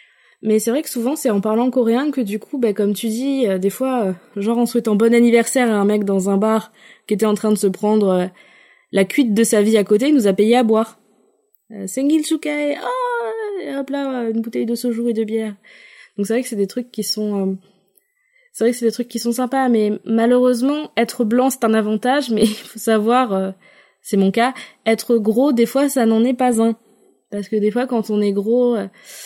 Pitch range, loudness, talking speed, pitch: 210-255 Hz, -18 LUFS, 240 wpm, 230 Hz